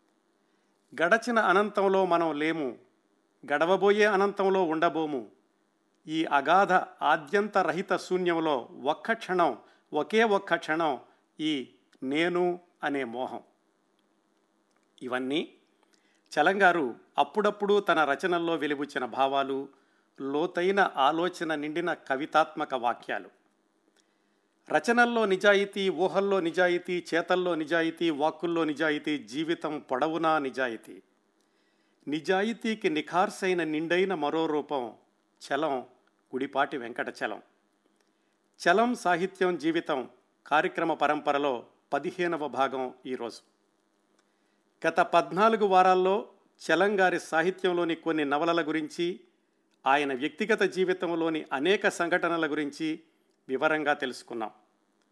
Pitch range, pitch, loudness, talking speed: 145-185 Hz, 165 Hz, -28 LUFS, 85 wpm